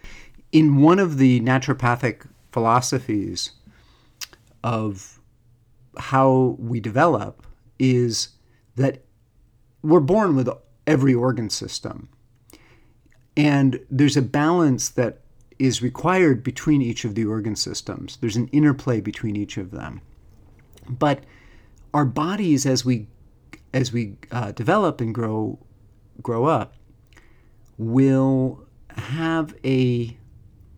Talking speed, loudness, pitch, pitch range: 105 wpm, -21 LUFS, 125 Hz, 115-135 Hz